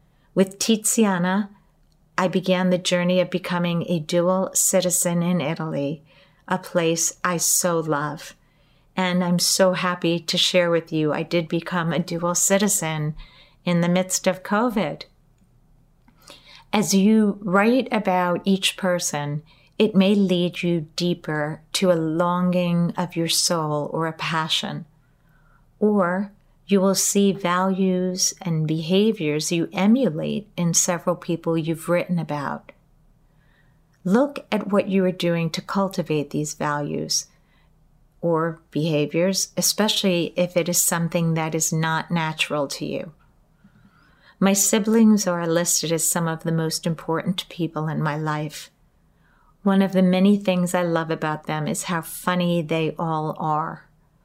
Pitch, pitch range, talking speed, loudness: 175 Hz, 160-185 Hz, 135 wpm, -22 LUFS